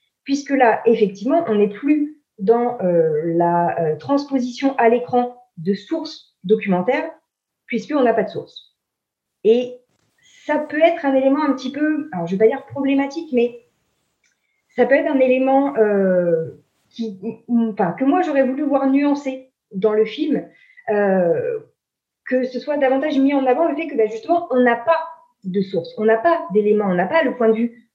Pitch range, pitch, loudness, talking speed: 220-290 Hz, 250 Hz, -19 LUFS, 180 wpm